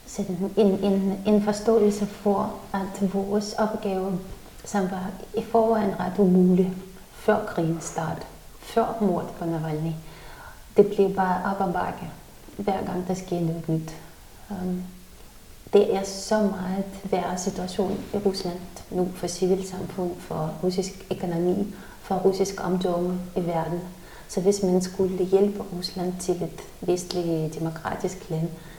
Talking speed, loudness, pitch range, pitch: 130 wpm, -26 LUFS, 180-200 Hz, 190 Hz